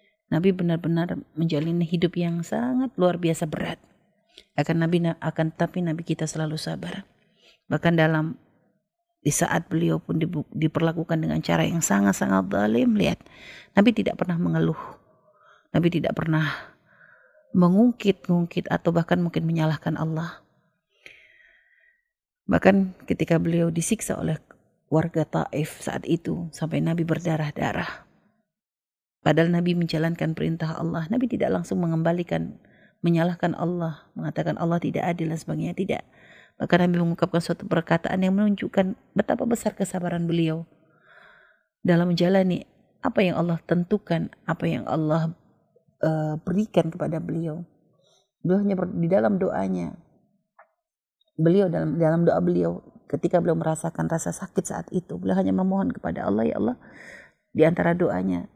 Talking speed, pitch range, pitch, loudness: 125 wpm, 160-185 Hz, 170 Hz, -24 LUFS